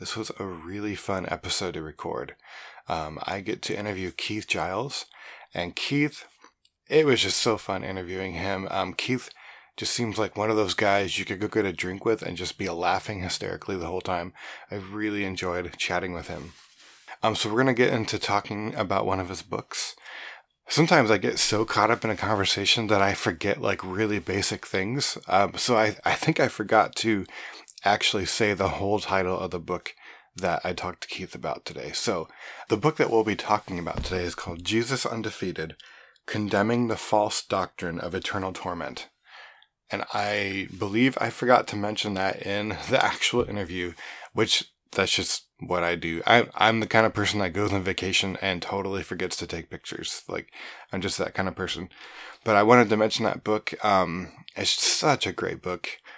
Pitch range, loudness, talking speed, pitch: 95-110 Hz, -26 LUFS, 190 wpm, 100 Hz